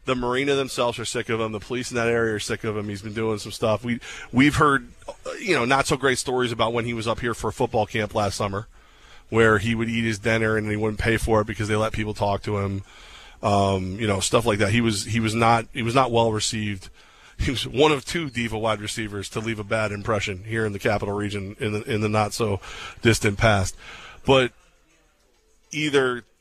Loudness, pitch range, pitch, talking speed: -23 LUFS, 105-120 Hz, 110 Hz, 240 wpm